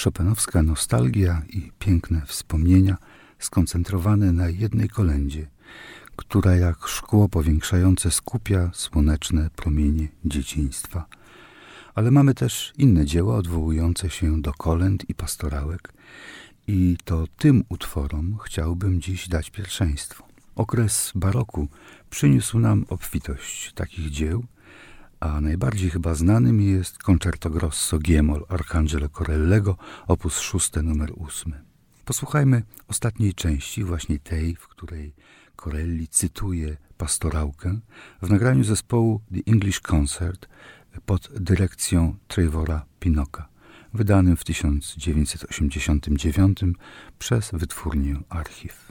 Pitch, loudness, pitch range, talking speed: 90 Hz, -23 LUFS, 80-100 Hz, 100 wpm